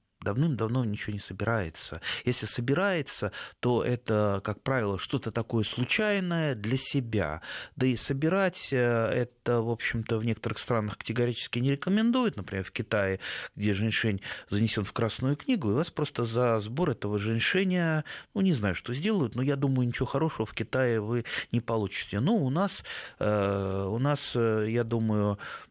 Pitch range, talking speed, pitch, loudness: 105-140 Hz, 150 wpm, 120 Hz, -29 LUFS